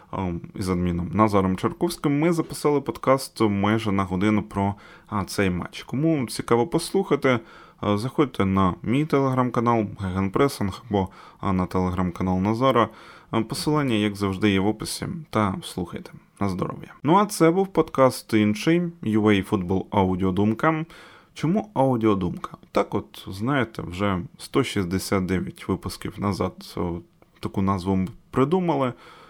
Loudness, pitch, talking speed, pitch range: -24 LUFS, 110 Hz, 115 wpm, 95-140 Hz